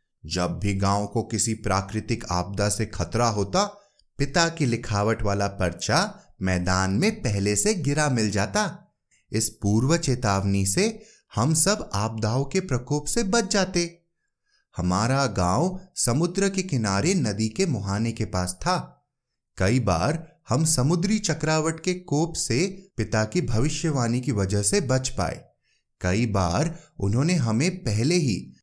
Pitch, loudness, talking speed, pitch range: 125 Hz, -24 LUFS, 140 wpm, 100-170 Hz